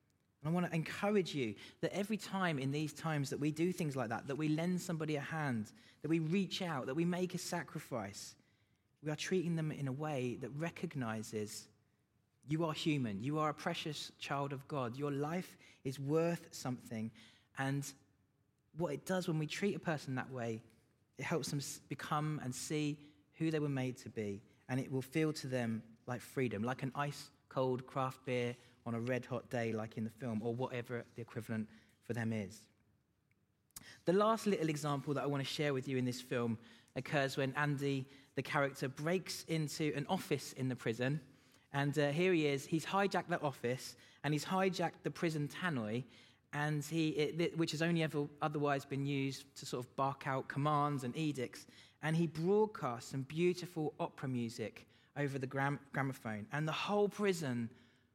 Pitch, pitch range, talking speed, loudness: 140 Hz, 125-155 Hz, 190 wpm, -39 LUFS